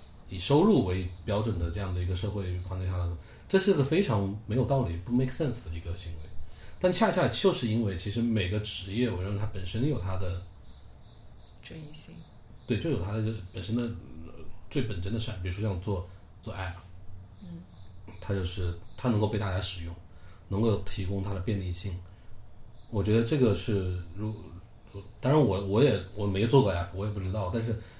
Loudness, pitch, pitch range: -30 LUFS, 100 Hz, 90-115 Hz